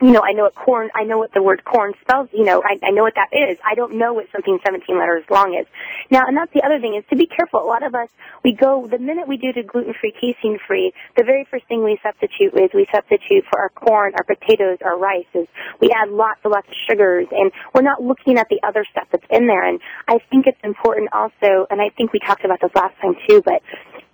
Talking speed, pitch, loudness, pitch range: 265 wpm, 220 Hz, -17 LUFS, 200-260 Hz